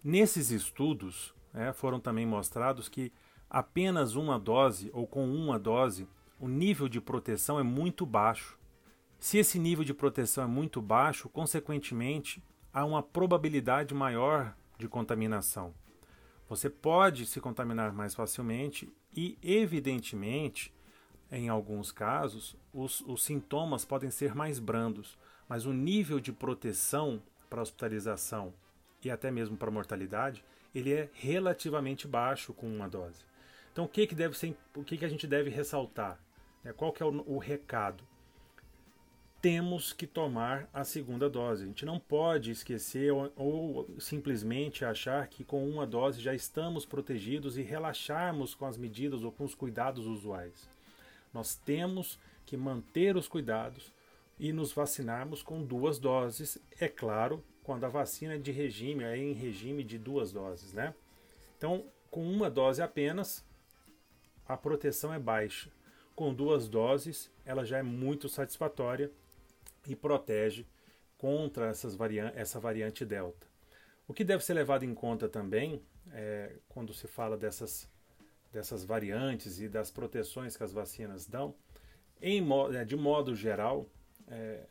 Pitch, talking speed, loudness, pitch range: 130 Hz, 145 wpm, -35 LUFS, 110-145 Hz